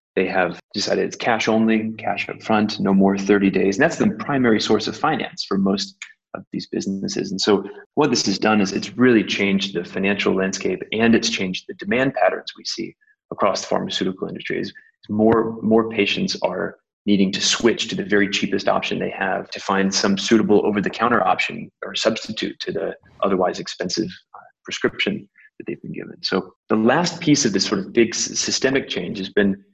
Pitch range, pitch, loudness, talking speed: 95-115 Hz, 105 Hz, -20 LUFS, 195 wpm